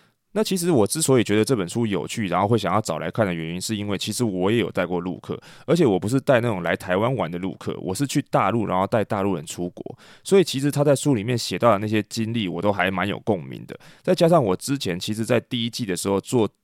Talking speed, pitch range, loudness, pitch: 380 characters per minute, 95-130 Hz, -22 LUFS, 110 Hz